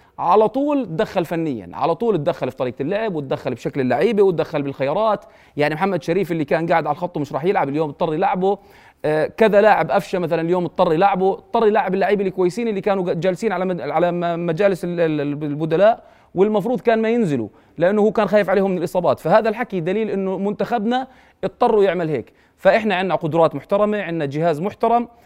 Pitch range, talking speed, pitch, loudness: 160-210 Hz, 175 wpm, 185 Hz, -19 LUFS